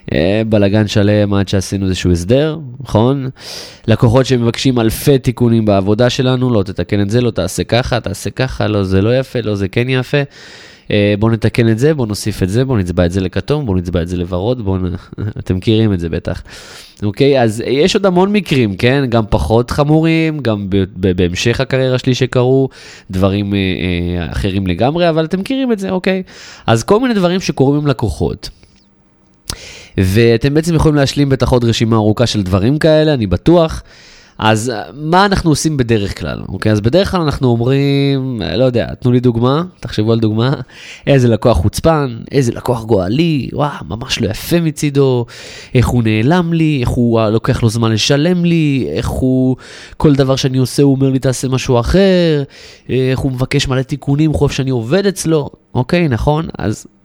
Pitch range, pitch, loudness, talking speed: 105-140 Hz, 125 Hz, -14 LUFS, 180 wpm